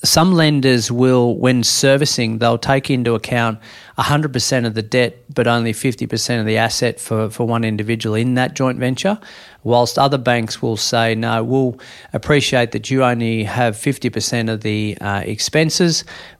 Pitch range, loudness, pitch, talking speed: 115-135 Hz, -17 LUFS, 120 Hz, 160 wpm